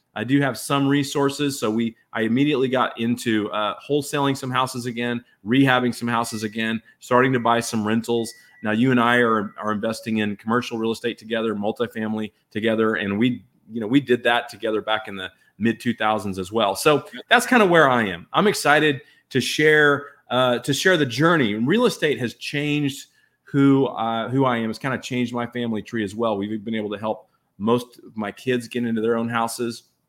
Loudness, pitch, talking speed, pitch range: -21 LUFS, 120 Hz, 205 wpm, 110-135 Hz